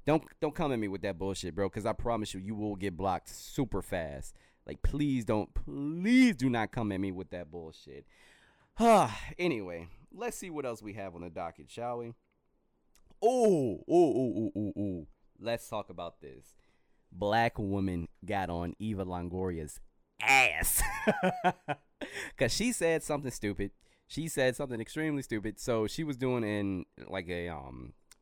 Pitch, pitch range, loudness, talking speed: 110 Hz, 95-145 Hz, -32 LUFS, 165 wpm